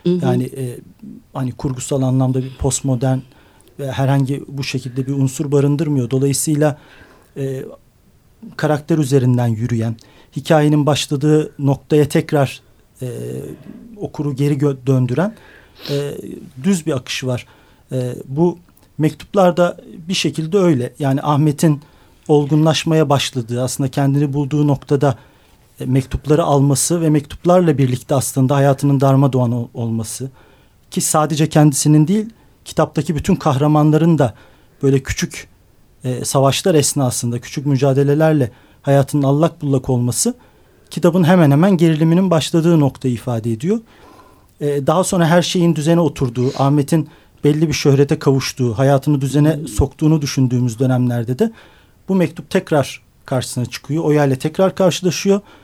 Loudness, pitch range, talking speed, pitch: -16 LUFS, 130-155 Hz, 115 wpm, 145 Hz